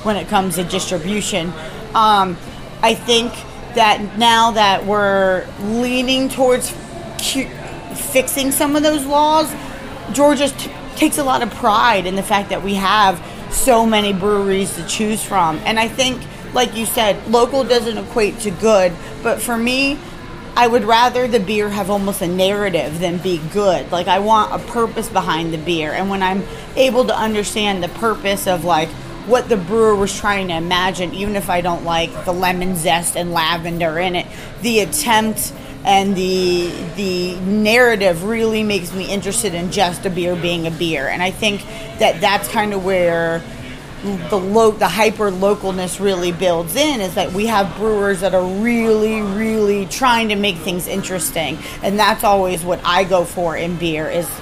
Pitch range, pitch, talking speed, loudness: 180-225 Hz, 200 Hz, 175 wpm, -16 LUFS